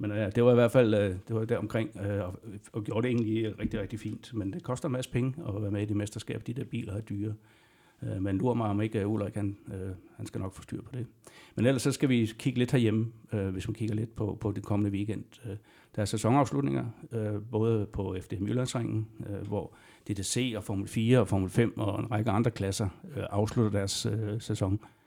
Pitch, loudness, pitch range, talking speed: 110 Hz, -31 LUFS, 105-120 Hz, 215 wpm